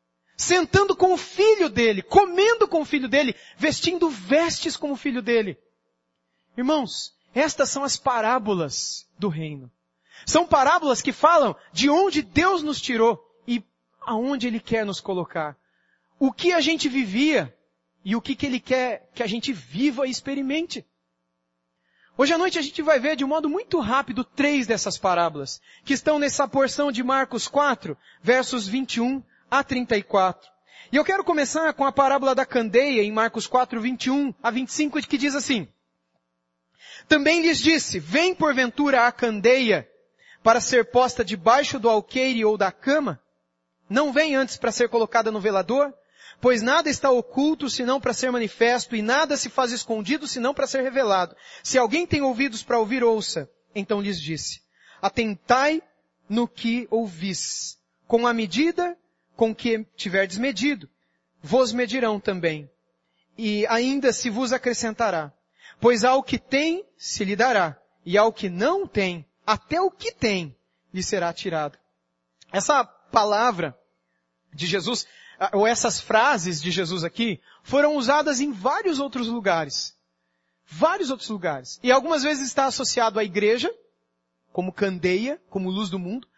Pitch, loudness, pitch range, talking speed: 245 Hz, -23 LUFS, 200-285 Hz, 155 wpm